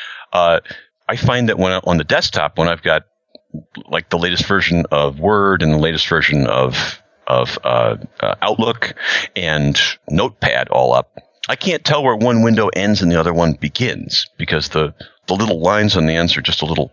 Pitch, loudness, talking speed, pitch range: 85 Hz, -16 LUFS, 195 wpm, 75-95 Hz